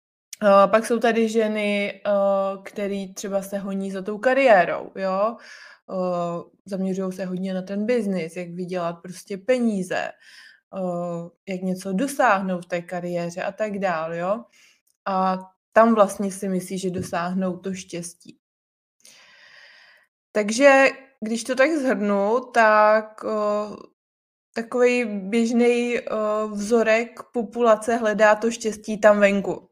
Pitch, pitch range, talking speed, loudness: 200 Hz, 185-225 Hz, 115 wpm, -22 LUFS